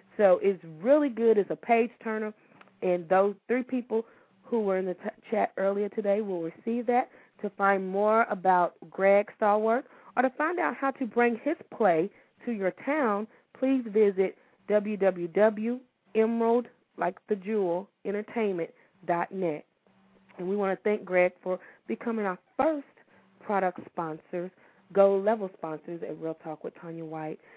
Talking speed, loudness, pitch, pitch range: 140 wpm, -28 LUFS, 205 Hz, 185-230 Hz